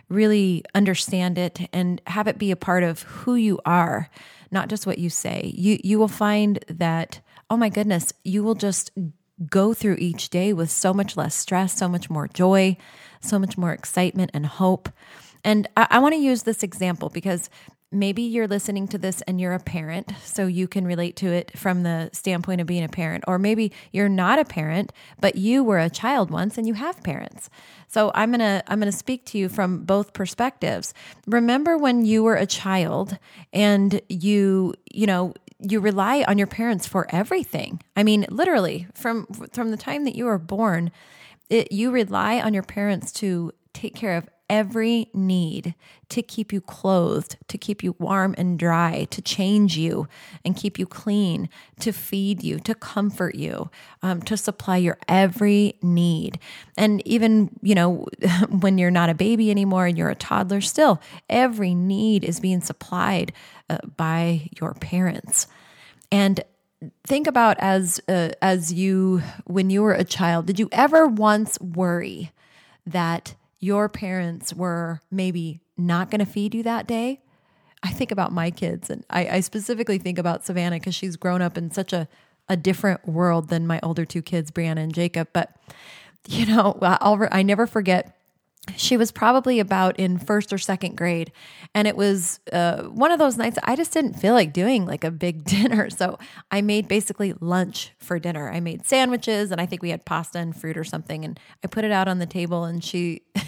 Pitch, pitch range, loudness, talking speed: 190 Hz, 175-210 Hz, -22 LUFS, 185 wpm